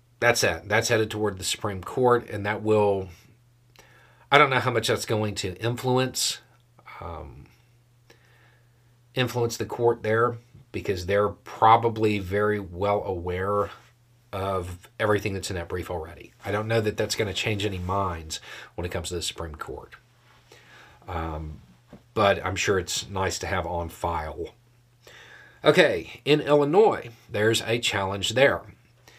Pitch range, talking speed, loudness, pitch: 95-120 Hz, 145 wpm, -25 LUFS, 110 Hz